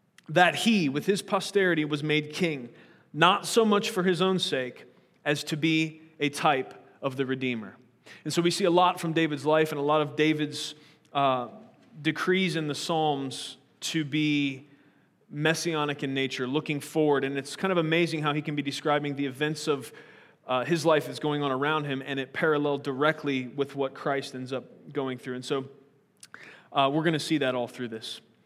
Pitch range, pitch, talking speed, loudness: 140-160 Hz, 150 Hz, 195 wpm, -27 LUFS